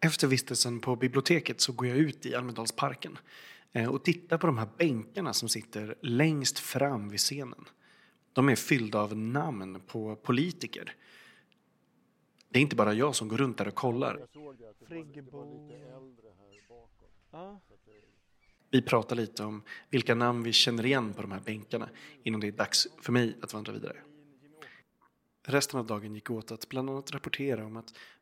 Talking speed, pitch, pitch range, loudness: 155 wpm, 120 Hz, 110-140 Hz, -30 LUFS